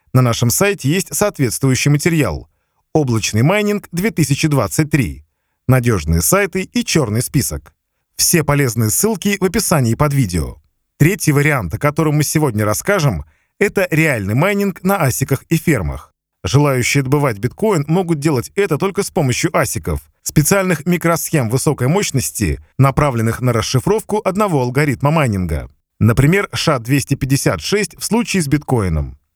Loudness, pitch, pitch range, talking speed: -16 LUFS, 145 Hz, 115-175 Hz, 125 wpm